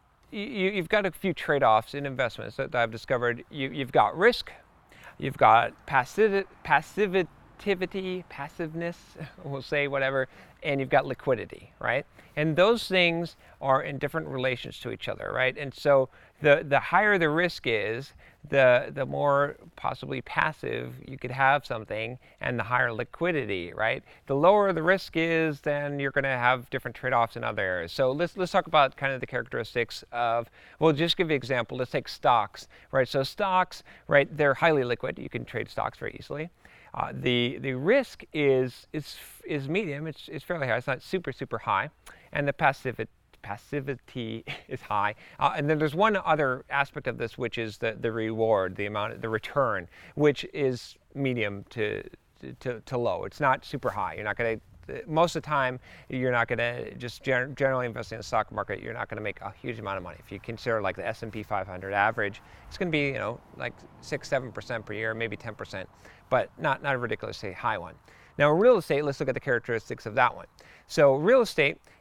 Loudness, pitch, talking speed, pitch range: -27 LUFS, 135 Hz, 190 wpm, 120-160 Hz